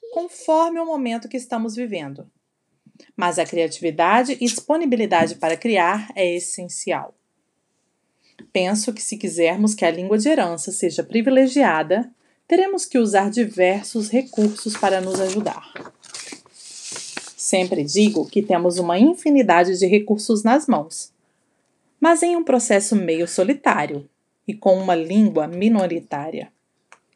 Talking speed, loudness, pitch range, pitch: 120 wpm, -19 LUFS, 180-245 Hz, 210 Hz